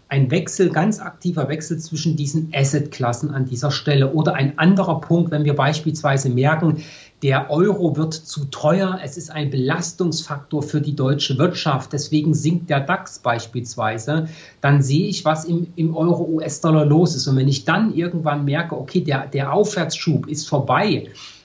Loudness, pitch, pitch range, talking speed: -20 LUFS, 155 Hz, 140-165 Hz, 160 wpm